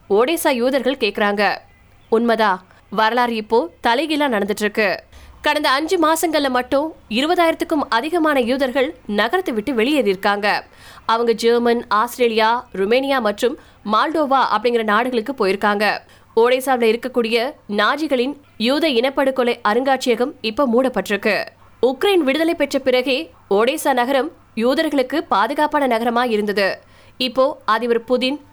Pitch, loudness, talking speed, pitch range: 250 Hz, -18 LUFS, 105 wpm, 220-285 Hz